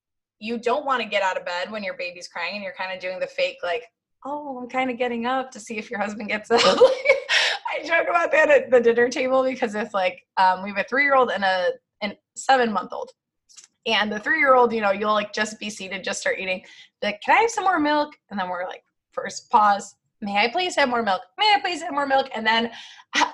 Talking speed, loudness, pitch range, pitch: 255 wpm, -22 LUFS, 205-275 Hz, 240 Hz